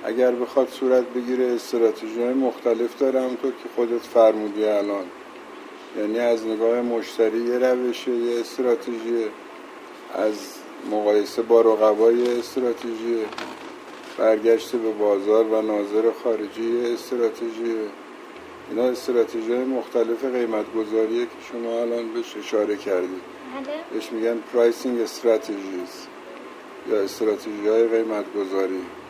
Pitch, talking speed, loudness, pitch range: 115 Hz, 105 wpm, -23 LUFS, 110-125 Hz